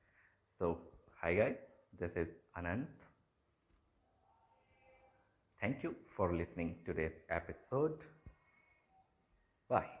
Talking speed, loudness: 80 wpm, -41 LUFS